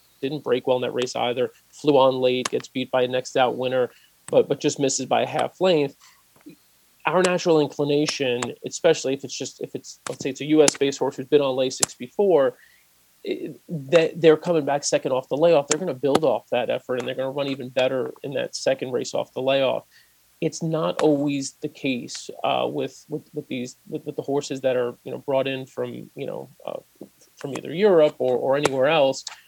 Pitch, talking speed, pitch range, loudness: 140 Hz, 220 wpm, 130-155 Hz, -23 LUFS